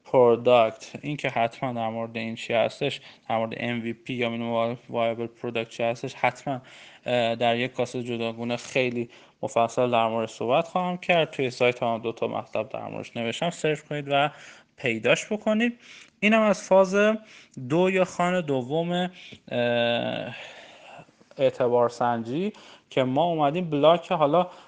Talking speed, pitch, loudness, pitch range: 140 wpm, 125 Hz, -25 LUFS, 115-170 Hz